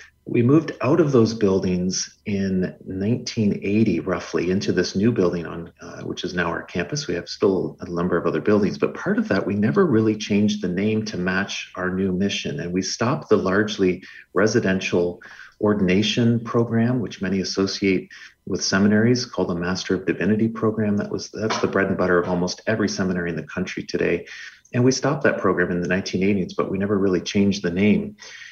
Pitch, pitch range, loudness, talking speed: 95 Hz, 90-110 Hz, -22 LUFS, 195 wpm